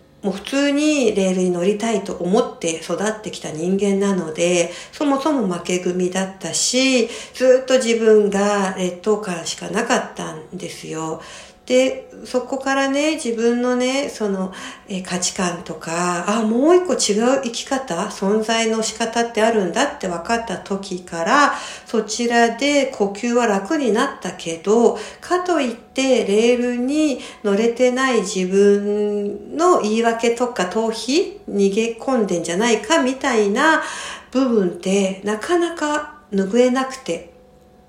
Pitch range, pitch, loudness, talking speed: 190-255 Hz, 220 Hz, -19 LUFS, 270 characters per minute